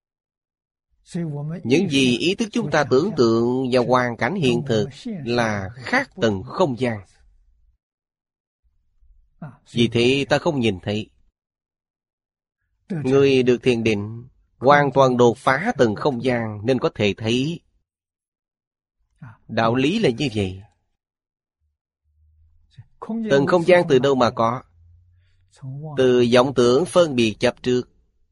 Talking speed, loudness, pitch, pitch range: 125 wpm, -20 LUFS, 120 Hz, 90-135 Hz